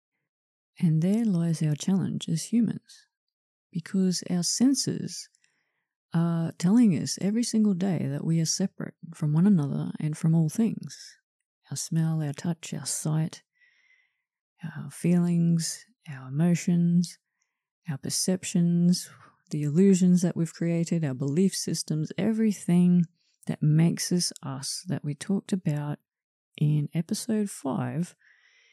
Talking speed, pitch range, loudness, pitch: 125 wpm, 160-200 Hz, -26 LUFS, 175 Hz